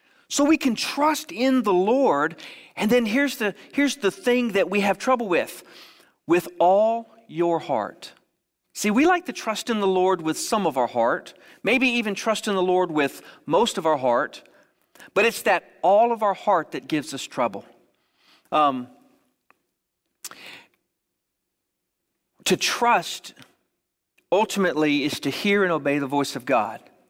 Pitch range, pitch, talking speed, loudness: 170-255 Hz, 210 Hz, 155 wpm, -22 LUFS